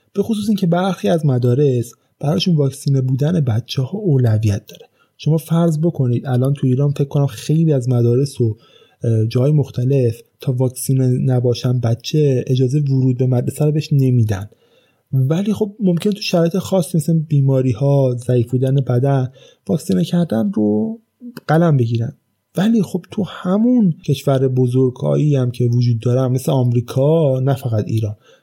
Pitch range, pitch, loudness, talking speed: 125-165 Hz, 135 Hz, -17 LUFS, 150 wpm